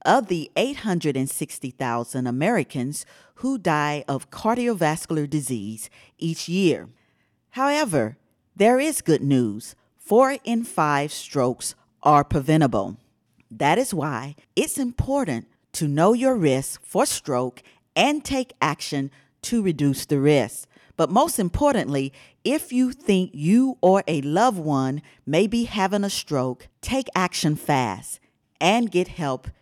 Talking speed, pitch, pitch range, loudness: 125 wpm, 155 Hz, 135-230 Hz, -23 LUFS